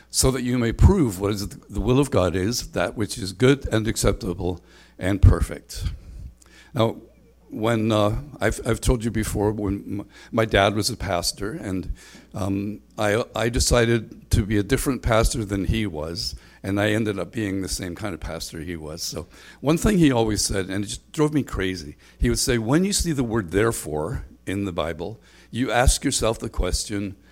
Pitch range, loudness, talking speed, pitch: 95-115 Hz, -23 LUFS, 195 wpm, 105 Hz